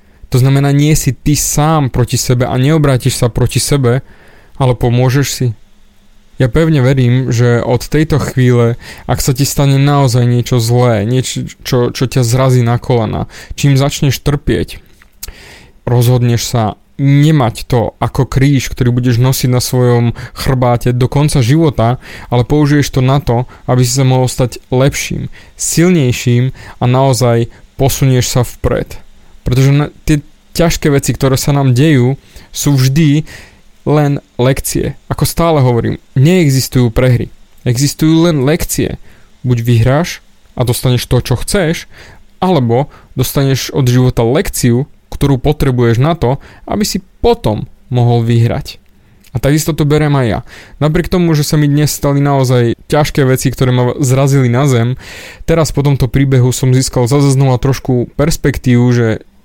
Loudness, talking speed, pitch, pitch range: -12 LUFS, 145 wpm, 130 Hz, 120-145 Hz